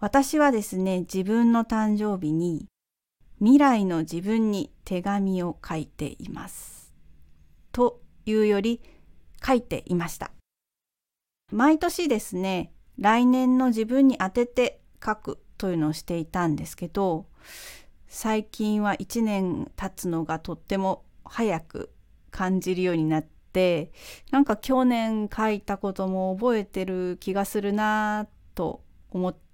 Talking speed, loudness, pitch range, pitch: 235 characters per minute, -25 LUFS, 180-225 Hz, 200 Hz